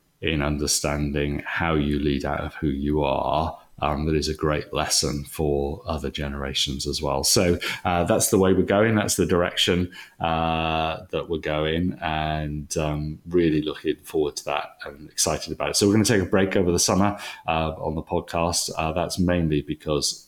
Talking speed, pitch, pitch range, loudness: 190 wpm, 80 Hz, 75-90 Hz, -23 LUFS